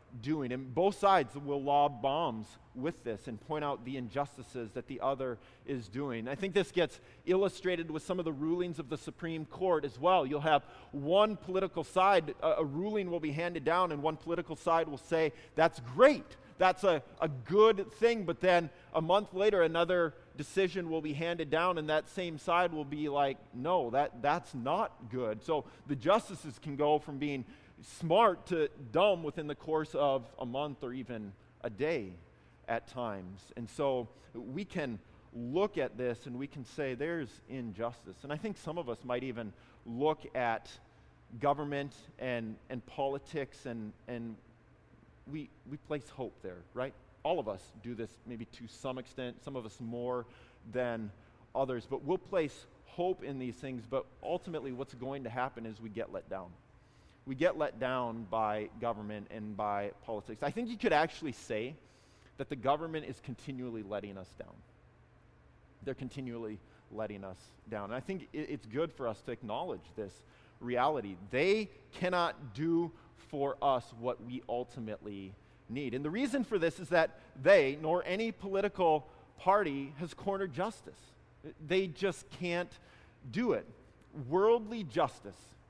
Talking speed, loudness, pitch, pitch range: 170 wpm, -34 LUFS, 140 Hz, 120-170 Hz